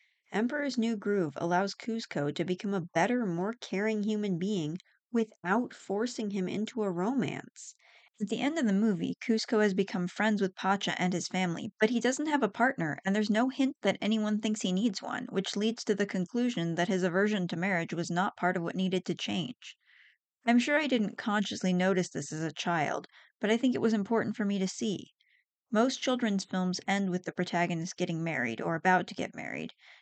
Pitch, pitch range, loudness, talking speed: 200 Hz, 180-225 Hz, -31 LUFS, 205 wpm